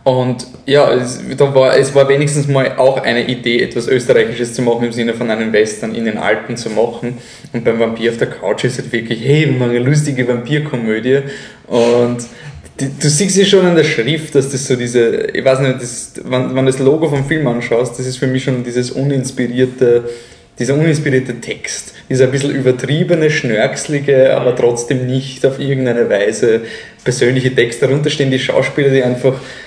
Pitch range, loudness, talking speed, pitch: 120-140 Hz, -14 LUFS, 190 wpm, 130 Hz